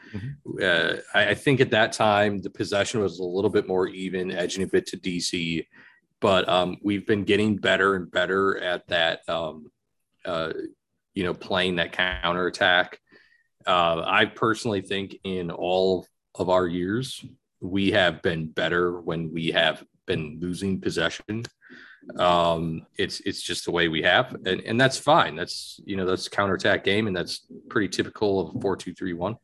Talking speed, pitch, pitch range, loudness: 170 wpm, 95 Hz, 90-100 Hz, -24 LUFS